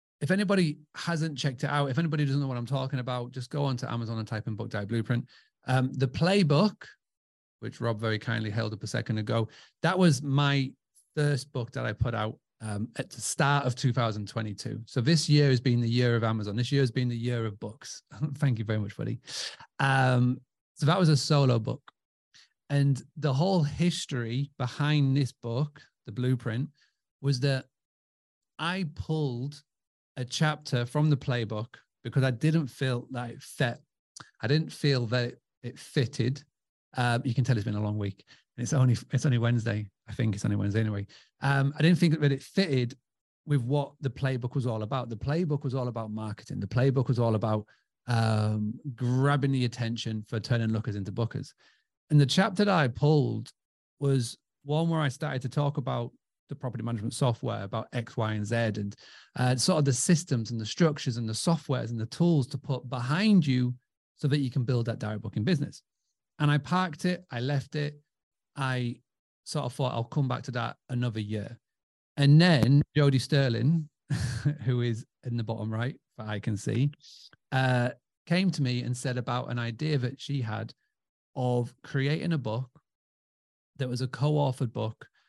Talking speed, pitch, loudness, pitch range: 190 wpm, 130 Hz, -29 LUFS, 115-145 Hz